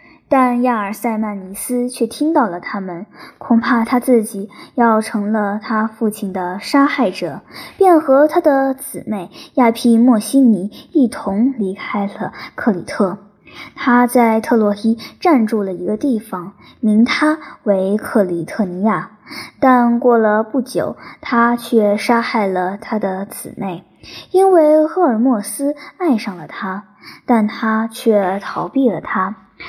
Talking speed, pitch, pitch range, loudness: 200 characters per minute, 225 Hz, 205-260 Hz, -16 LUFS